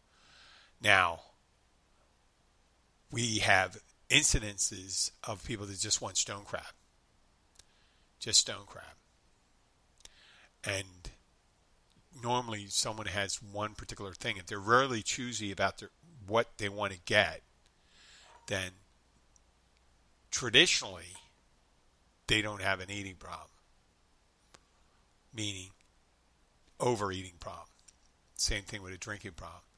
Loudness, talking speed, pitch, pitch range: -32 LUFS, 100 wpm, 100 Hz, 85-105 Hz